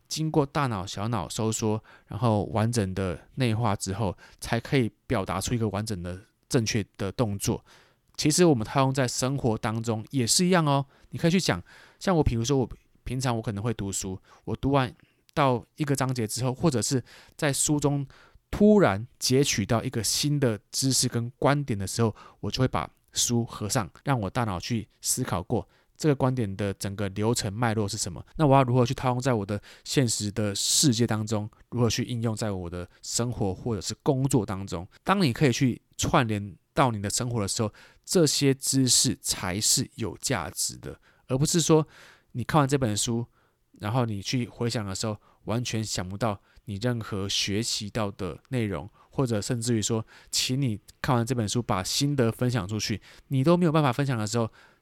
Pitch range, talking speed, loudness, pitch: 105-135 Hz, 280 characters per minute, -26 LUFS, 120 Hz